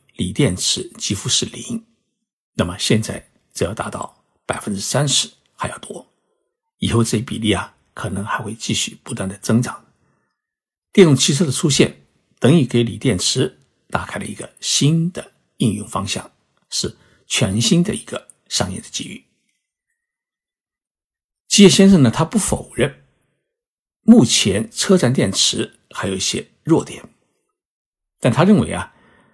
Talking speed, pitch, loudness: 210 characters per minute, 180 Hz, -18 LUFS